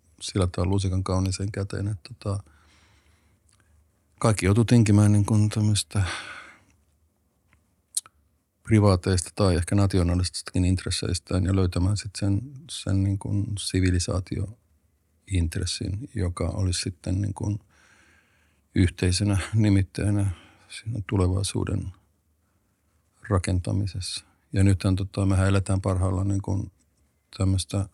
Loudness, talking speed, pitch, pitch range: -25 LUFS, 90 wpm, 95 Hz, 90-100 Hz